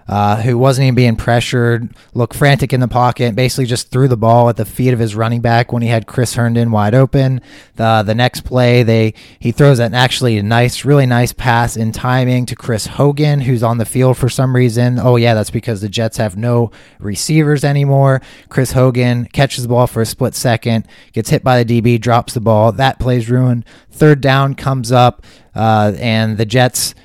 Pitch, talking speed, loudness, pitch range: 120 Hz, 205 wpm, -13 LUFS, 115-130 Hz